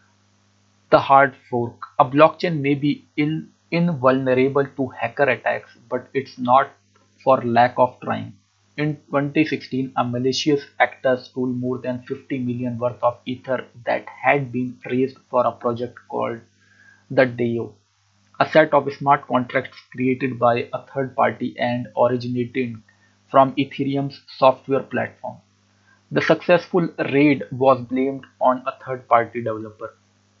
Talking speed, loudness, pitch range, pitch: 130 wpm, -21 LUFS, 120-140 Hz, 130 Hz